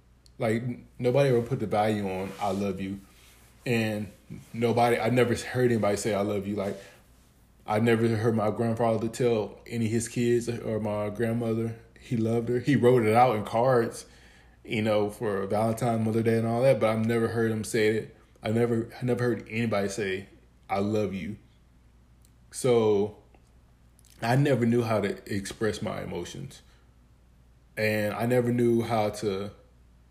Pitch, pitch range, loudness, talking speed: 110 Hz, 100-115 Hz, -27 LUFS, 165 wpm